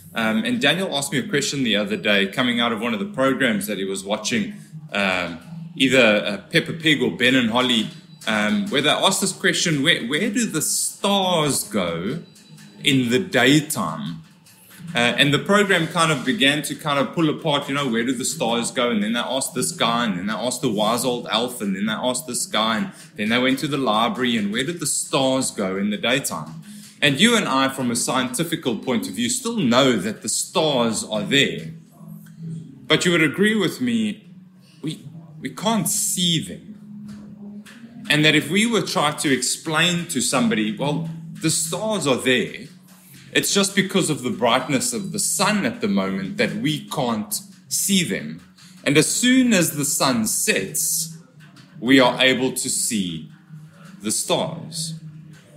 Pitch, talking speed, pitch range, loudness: 170 Hz, 190 wpm, 145-200 Hz, -20 LUFS